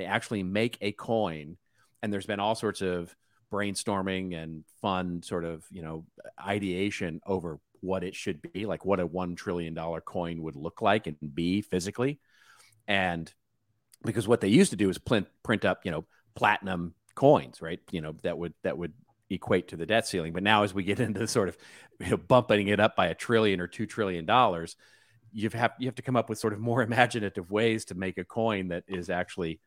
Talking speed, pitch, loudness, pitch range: 210 wpm, 100 Hz, -29 LUFS, 90-110 Hz